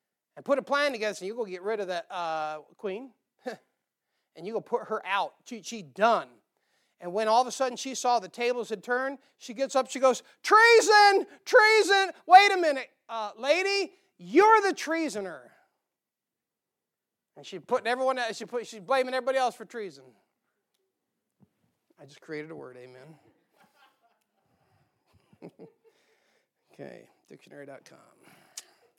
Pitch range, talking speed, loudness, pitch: 210-295 Hz, 145 wpm, -25 LUFS, 245 Hz